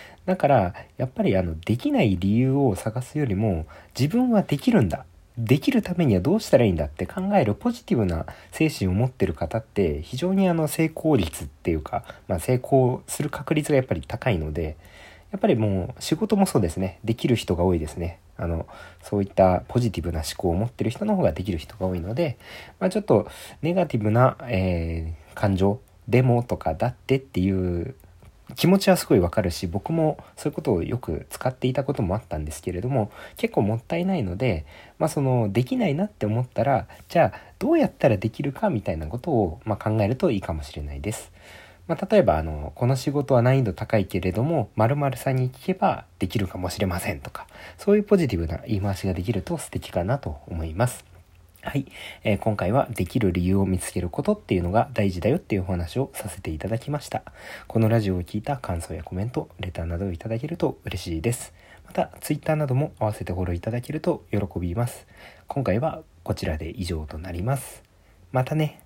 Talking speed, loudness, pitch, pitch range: 410 characters per minute, -25 LUFS, 110 Hz, 90-135 Hz